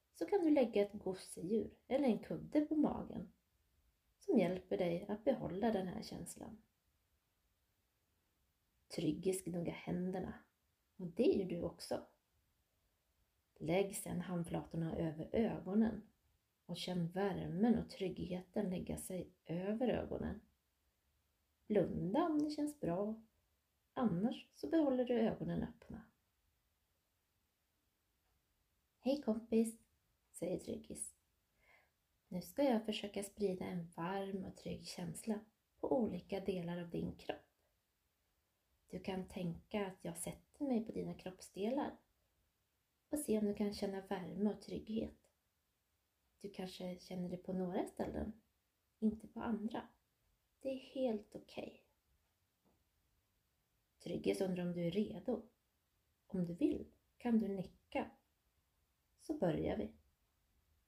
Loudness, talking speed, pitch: -41 LUFS, 120 wpm, 185 Hz